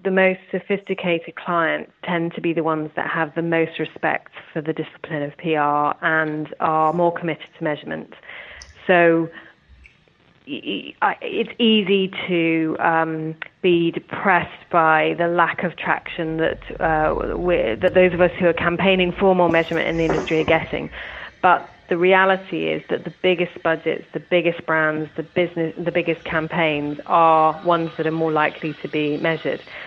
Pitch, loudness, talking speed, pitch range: 165 Hz, -20 LUFS, 160 wpm, 160-175 Hz